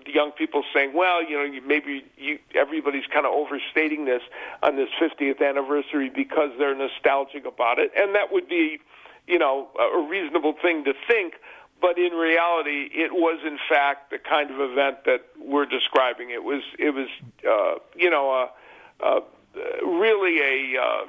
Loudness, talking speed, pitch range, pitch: -23 LUFS, 175 wpm, 140-175 Hz, 150 Hz